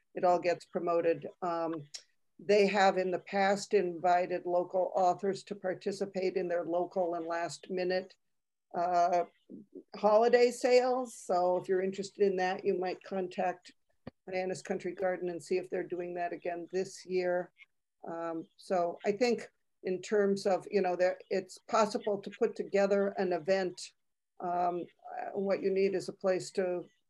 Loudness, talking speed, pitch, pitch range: -32 LUFS, 155 wpm, 185 Hz, 175-200 Hz